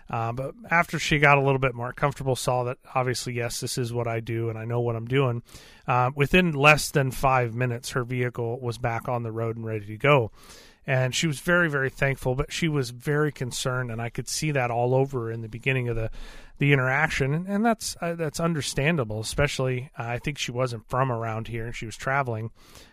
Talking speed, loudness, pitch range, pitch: 230 wpm, -25 LUFS, 120-145 Hz, 130 Hz